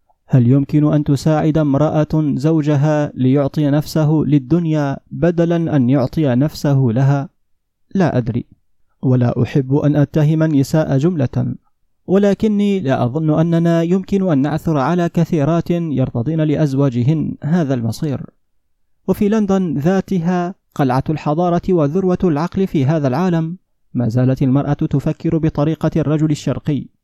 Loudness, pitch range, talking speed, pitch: -16 LUFS, 140-170 Hz, 115 wpm, 155 Hz